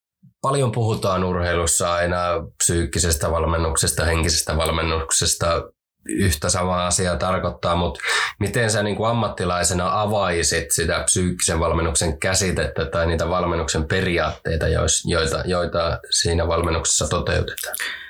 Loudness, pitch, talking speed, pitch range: -20 LUFS, 85 Hz, 105 wpm, 85-95 Hz